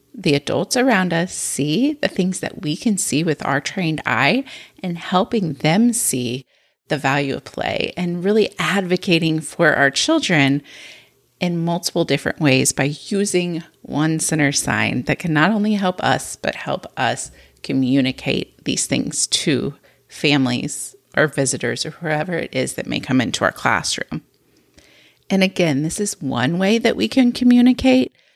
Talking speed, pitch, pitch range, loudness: 155 wpm, 170 Hz, 145-210 Hz, -19 LUFS